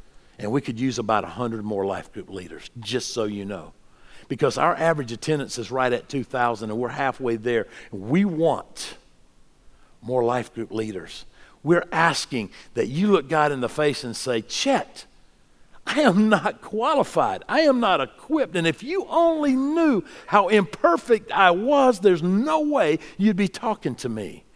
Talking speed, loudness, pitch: 170 wpm, -22 LUFS, 150 Hz